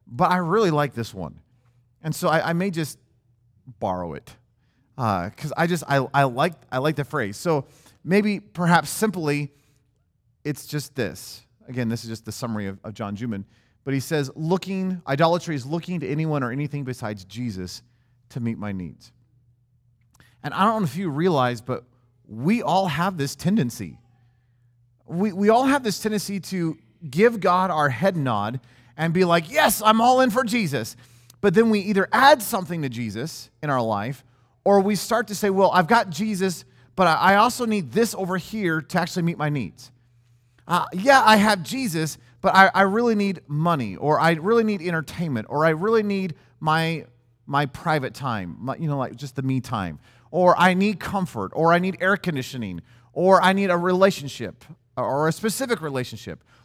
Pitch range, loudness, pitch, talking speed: 120-185 Hz, -22 LUFS, 150 Hz, 185 wpm